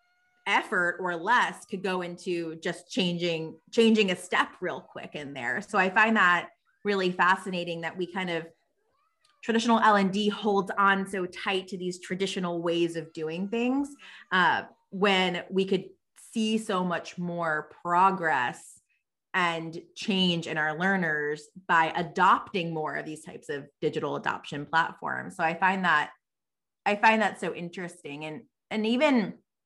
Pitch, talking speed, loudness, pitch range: 185 Hz, 155 wpm, -27 LUFS, 170-205 Hz